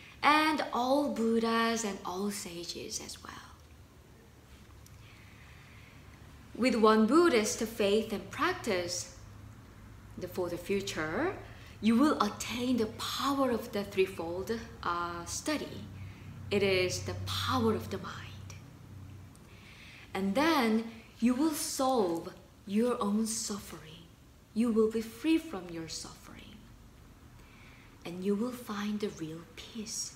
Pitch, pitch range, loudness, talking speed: 205 Hz, 160-235 Hz, -31 LUFS, 110 wpm